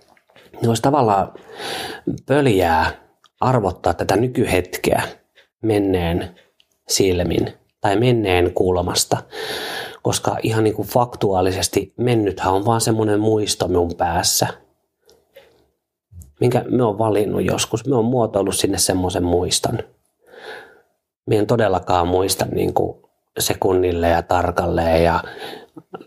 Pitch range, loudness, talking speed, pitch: 90-115 Hz, -19 LUFS, 100 wpm, 95 Hz